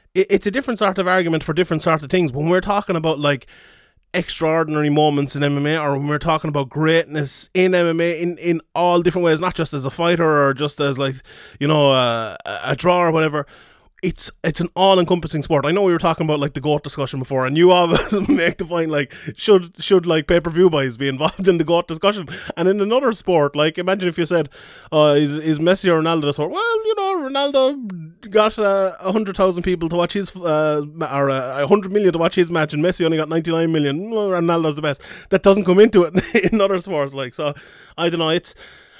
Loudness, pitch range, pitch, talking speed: -18 LUFS, 150-185 Hz, 170 Hz, 225 wpm